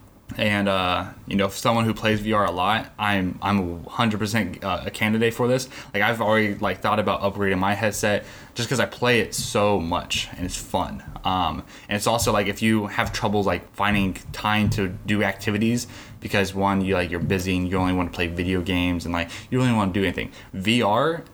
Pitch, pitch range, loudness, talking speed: 105 Hz, 95-110 Hz, -23 LUFS, 215 wpm